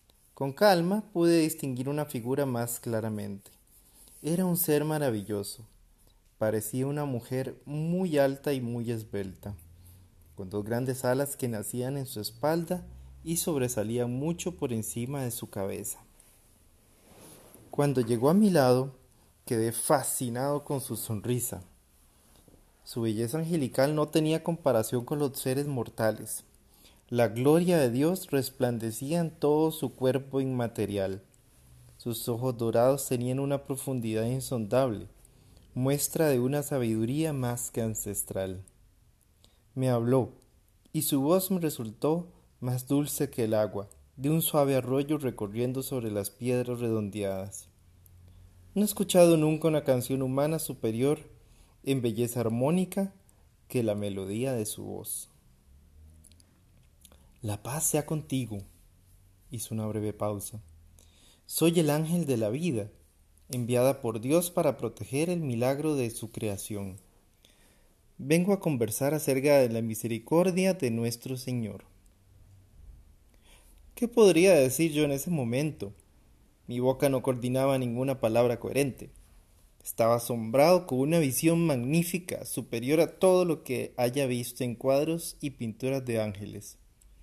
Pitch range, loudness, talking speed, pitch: 105-145 Hz, -29 LUFS, 130 wpm, 125 Hz